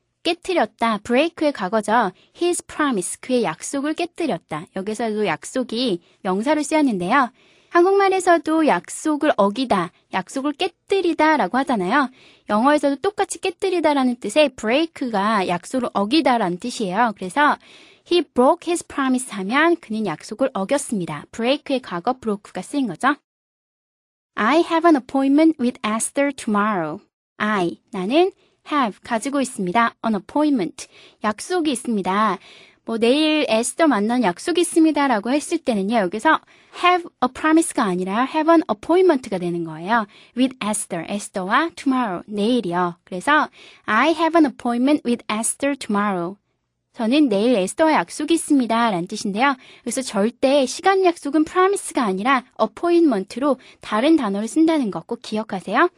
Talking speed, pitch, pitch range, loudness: 450 characters per minute, 260 Hz, 210-315 Hz, -20 LUFS